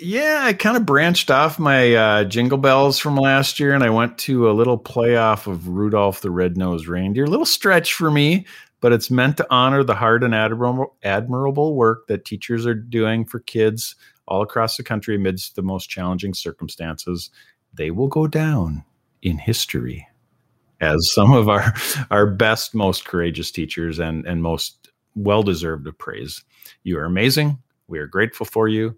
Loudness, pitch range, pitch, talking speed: -18 LUFS, 95-135 Hz, 115 Hz, 175 wpm